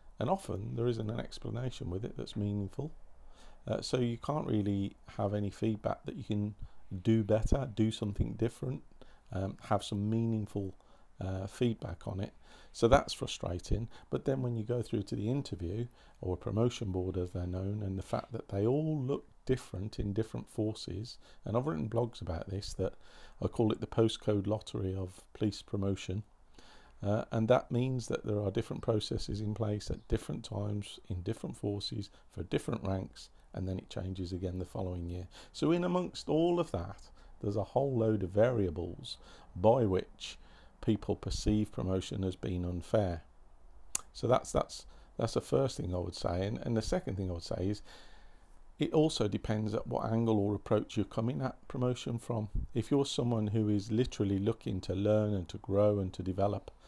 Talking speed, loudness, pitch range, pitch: 185 wpm, -35 LUFS, 95-115 Hz, 105 Hz